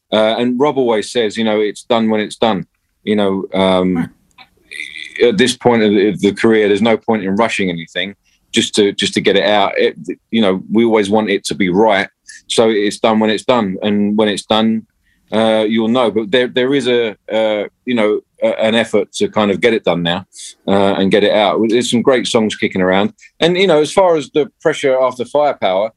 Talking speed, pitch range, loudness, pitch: 220 wpm, 100-120 Hz, -14 LUFS, 110 Hz